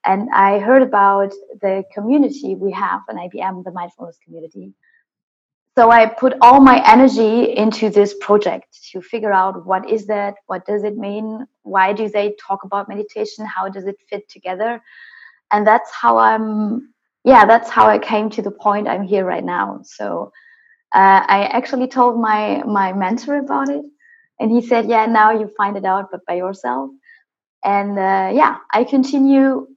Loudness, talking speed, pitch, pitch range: -15 LUFS, 175 wpm, 210 Hz, 195-240 Hz